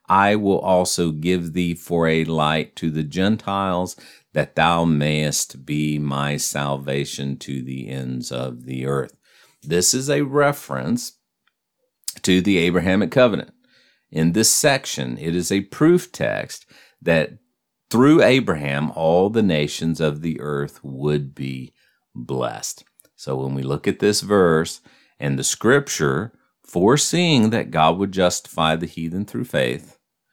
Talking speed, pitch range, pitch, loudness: 140 wpm, 70-95 Hz, 80 Hz, -20 LUFS